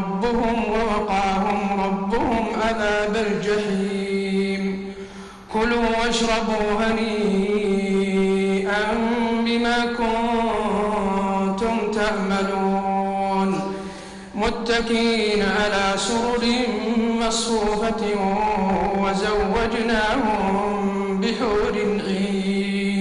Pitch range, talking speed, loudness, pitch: 195-225 Hz, 40 wpm, -21 LUFS, 210 Hz